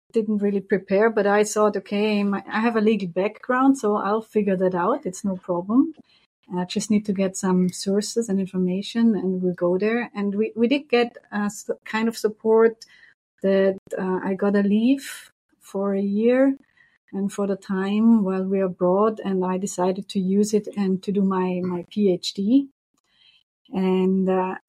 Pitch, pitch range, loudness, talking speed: 205 Hz, 190-220 Hz, -22 LUFS, 180 wpm